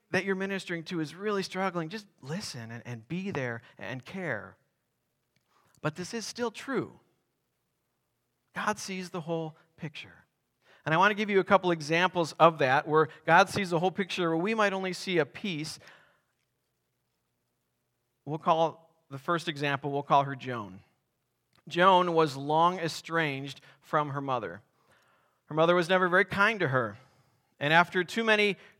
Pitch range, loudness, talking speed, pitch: 140-185 Hz, -28 LUFS, 160 wpm, 165 Hz